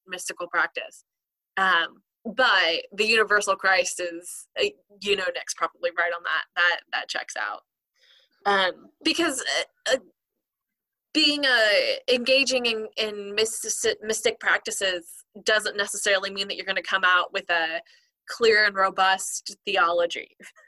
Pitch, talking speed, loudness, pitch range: 210 Hz, 130 wpm, -23 LUFS, 190-250 Hz